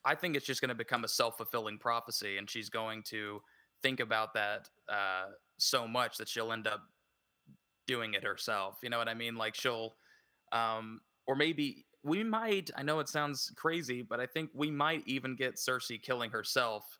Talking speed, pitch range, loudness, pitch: 195 wpm, 110-145 Hz, -35 LUFS, 120 Hz